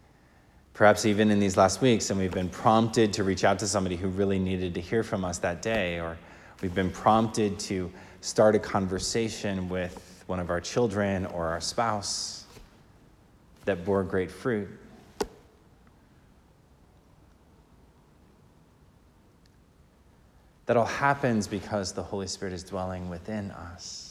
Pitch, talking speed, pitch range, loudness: 95 Hz, 135 wpm, 90-105 Hz, -27 LUFS